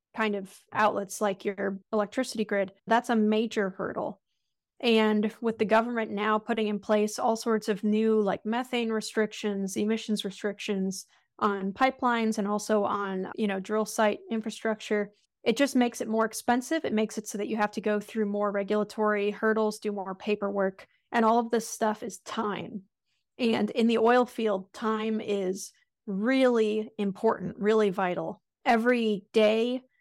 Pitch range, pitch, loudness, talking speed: 205-225 Hz, 215 Hz, -28 LUFS, 160 wpm